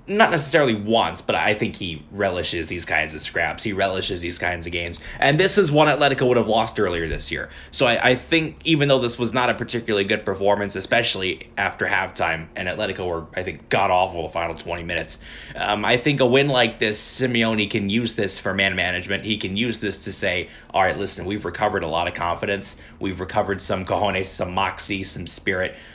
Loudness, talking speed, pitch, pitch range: -21 LUFS, 215 wpm, 100 Hz, 90-120 Hz